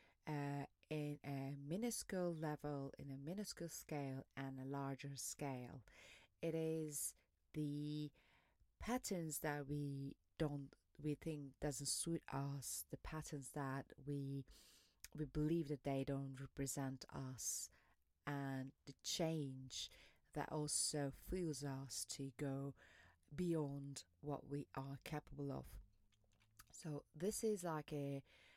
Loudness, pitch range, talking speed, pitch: -47 LUFS, 135-155 Hz, 120 wpm, 140 Hz